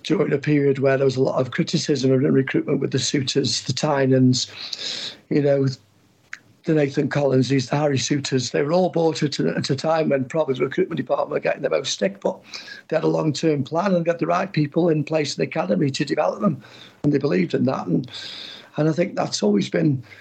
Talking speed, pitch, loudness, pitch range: 220 wpm, 145 Hz, -21 LUFS, 130-155 Hz